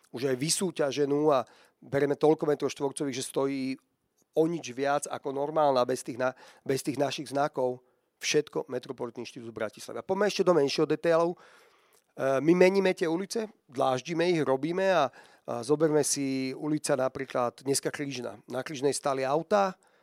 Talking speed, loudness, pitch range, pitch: 155 wpm, -29 LUFS, 130-160 Hz, 145 Hz